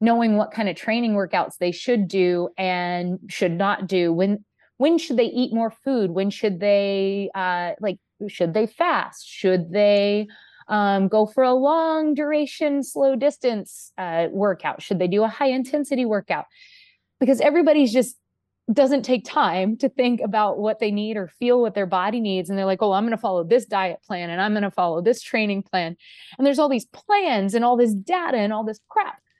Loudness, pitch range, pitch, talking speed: -22 LUFS, 195-255 Hz, 215 Hz, 200 wpm